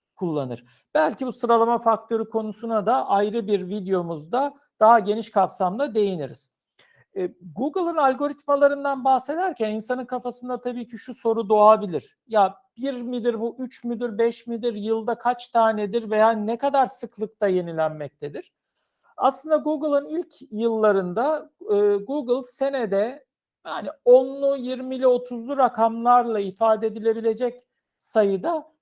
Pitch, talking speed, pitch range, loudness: 235 Hz, 110 wpm, 215-265 Hz, -23 LUFS